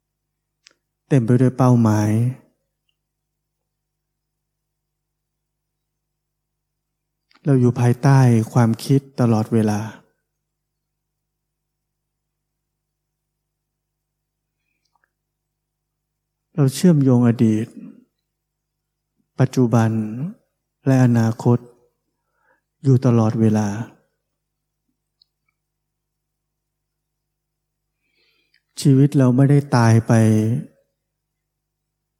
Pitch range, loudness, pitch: 120-155 Hz, -17 LUFS, 150 Hz